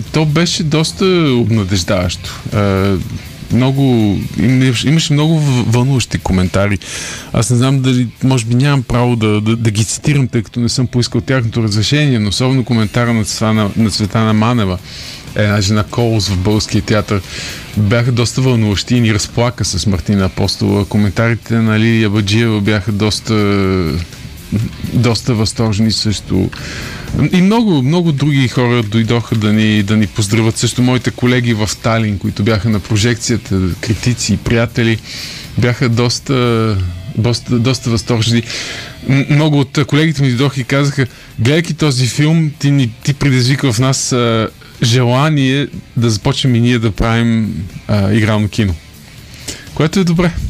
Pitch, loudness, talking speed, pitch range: 115 Hz, -13 LUFS, 140 wpm, 105-130 Hz